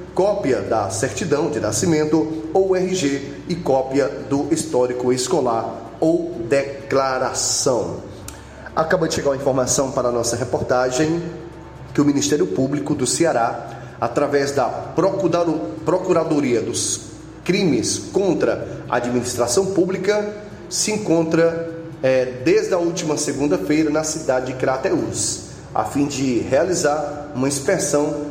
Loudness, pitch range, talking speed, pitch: -20 LUFS, 130-165 Hz, 115 wpm, 145 Hz